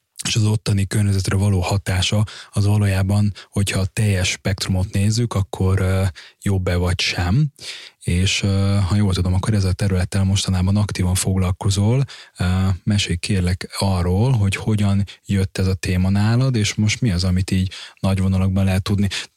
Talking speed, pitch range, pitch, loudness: 150 wpm, 95-105 Hz, 100 Hz, -20 LUFS